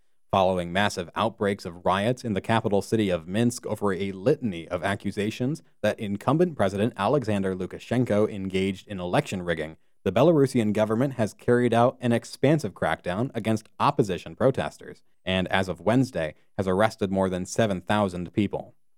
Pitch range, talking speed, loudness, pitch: 95-115 Hz, 150 wpm, -26 LUFS, 105 Hz